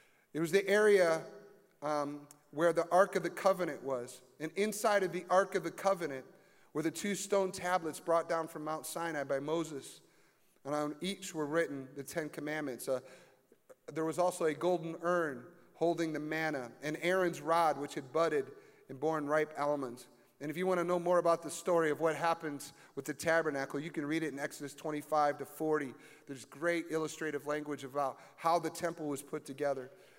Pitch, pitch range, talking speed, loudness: 160 Hz, 145-175 Hz, 190 wpm, -35 LUFS